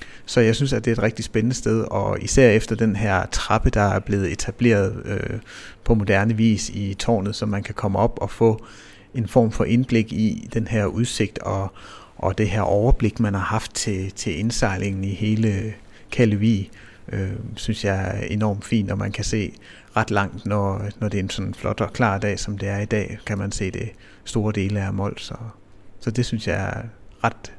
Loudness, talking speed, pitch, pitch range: -22 LUFS, 210 wpm, 105 Hz, 100-115 Hz